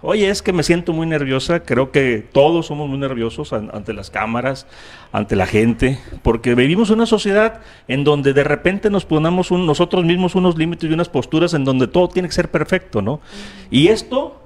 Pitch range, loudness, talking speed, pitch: 130-180 Hz, -17 LUFS, 200 wpm, 155 Hz